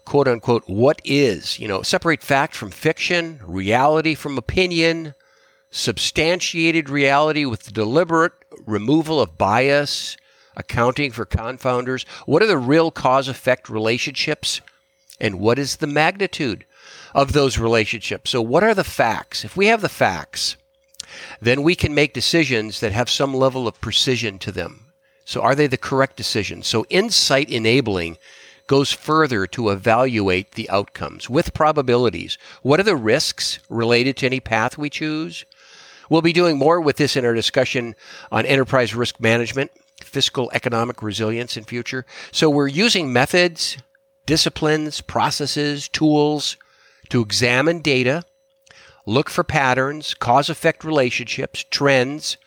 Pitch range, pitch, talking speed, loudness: 115-155 Hz, 135 Hz, 135 wpm, -19 LUFS